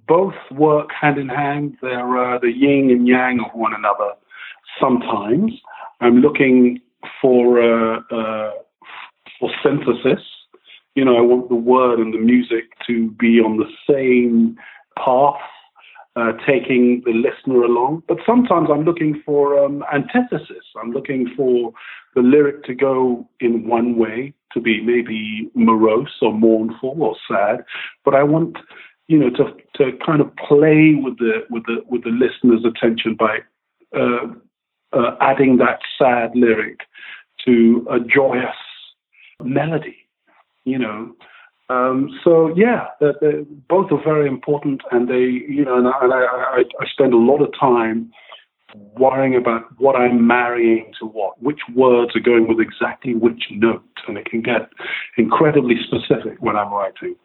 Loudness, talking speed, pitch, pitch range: -17 LUFS, 150 wpm, 125 Hz, 115-140 Hz